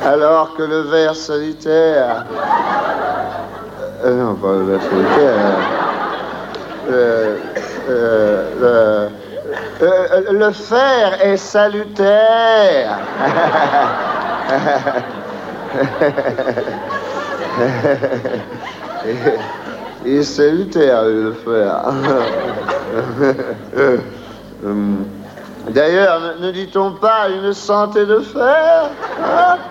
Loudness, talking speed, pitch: -15 LUFS, 60 wpm, 160 Hz